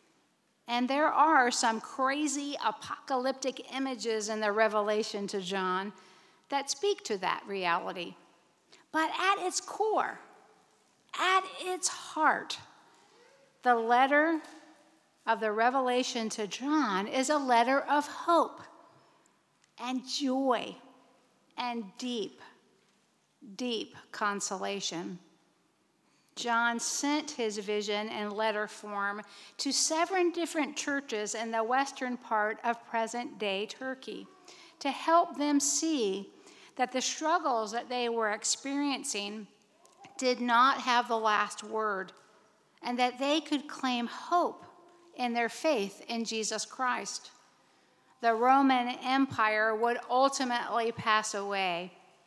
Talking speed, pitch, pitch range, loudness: 110 wpm, 245 Hz, 215-290 Hz, -30 LUFS